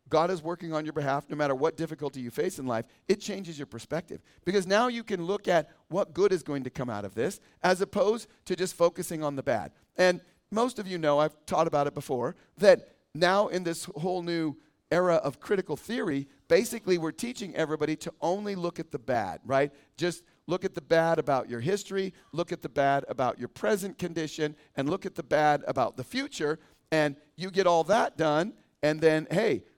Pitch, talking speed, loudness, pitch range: 165 Hz, 210 wpm, -29 LUFS, 150-185 Hz